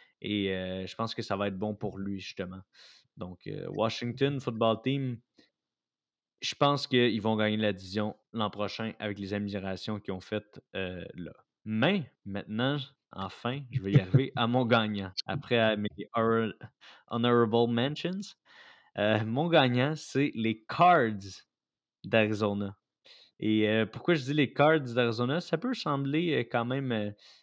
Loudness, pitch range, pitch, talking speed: -30 LUFS, 105-135 Hz, 115 Hz, 155 wpm